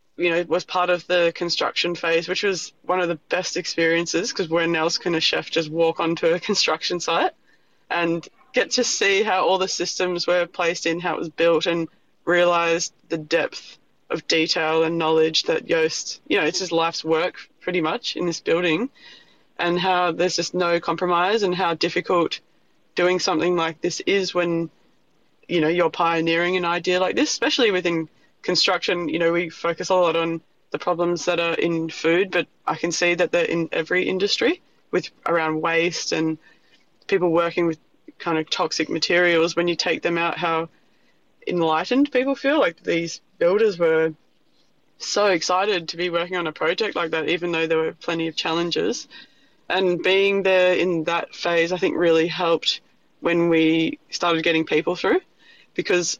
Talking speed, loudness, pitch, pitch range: 180 wpm, -21 LUFS, 170 Hz, 165-180 Hz